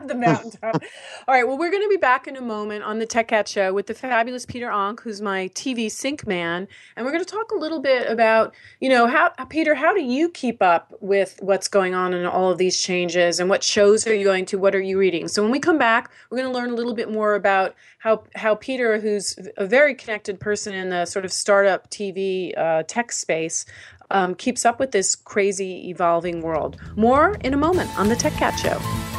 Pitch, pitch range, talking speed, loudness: 210 Hz, 190-250 Hz, 235 wpm, -21 LUFS